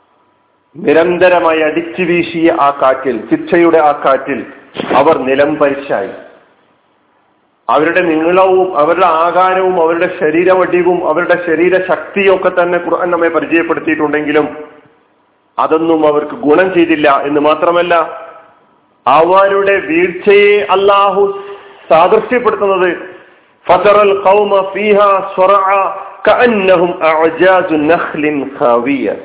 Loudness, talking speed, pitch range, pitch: -10 LUFS, 70 wpm, 155-190 Hz, 175 Hz